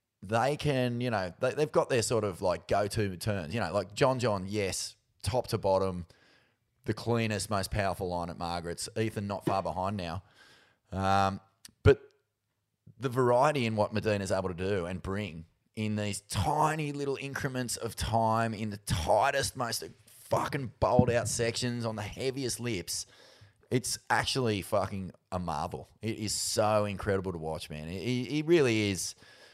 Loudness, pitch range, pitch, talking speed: -31 LUFS, 95-115 Hz, 105 Hz, 165 wpm